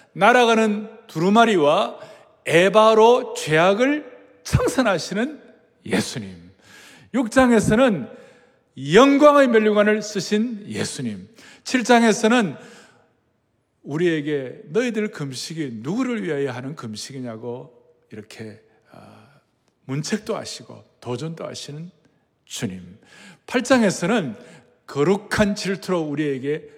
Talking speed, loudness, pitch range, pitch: 215 characters per minute, -19 LUFS, 140-230 Hz, 195 Hz